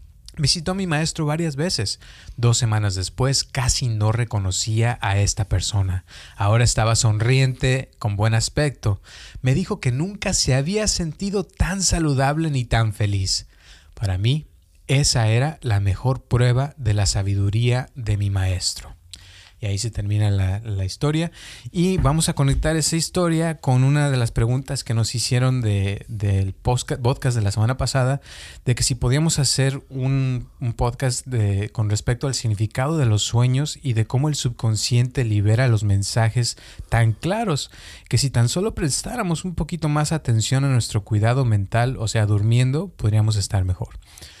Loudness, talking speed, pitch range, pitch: -21 LUFS, 160 wpm, 105-140 Hz, 120 Hz